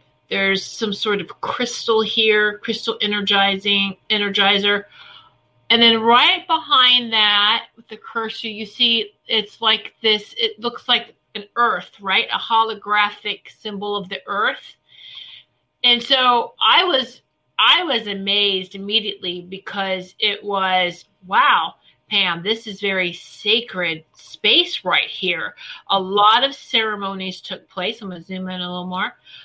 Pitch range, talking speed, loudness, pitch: 195-230 Hz, 135 wpm, -18 LUFS, 210 Hz